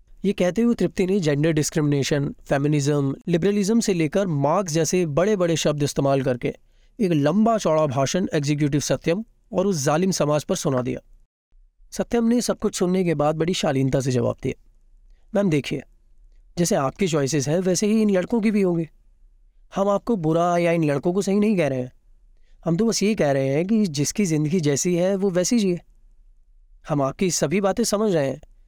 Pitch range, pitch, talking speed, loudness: 145-200 Hz, 170 Hz, 190 wpm, -22 LUFS